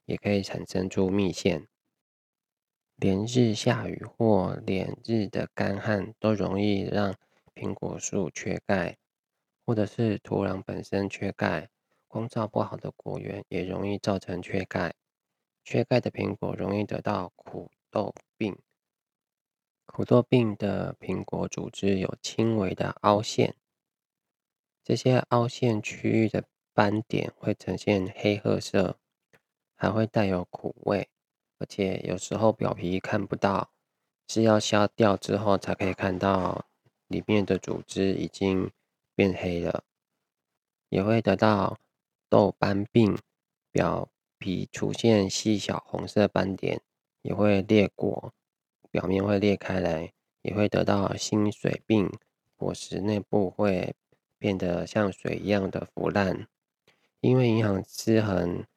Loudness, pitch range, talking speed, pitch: -27 LUFS, 95-110 Hz, 185 characters per minute, 100 Hz